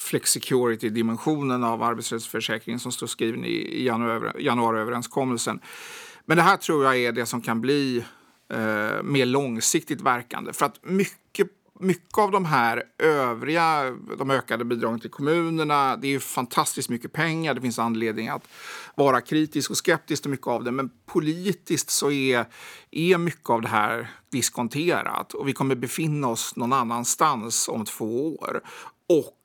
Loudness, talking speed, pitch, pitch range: -24 LUFS, 150 wpm, 125 Hz, 115-150 Hz